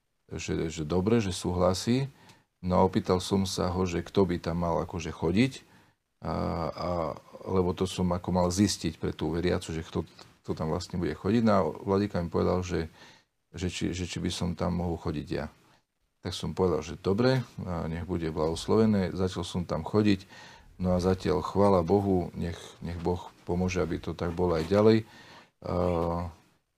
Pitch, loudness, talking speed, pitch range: 90 Hz, -29 LUFS, 180 wpm, 85-100 Hz